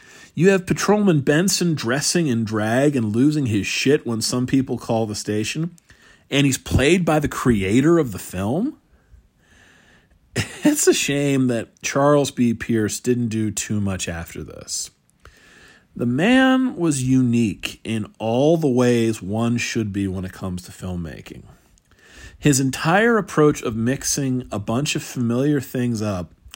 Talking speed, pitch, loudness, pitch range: 150 wpm, 125 Hz, -20 LUFS, 110-150 Hz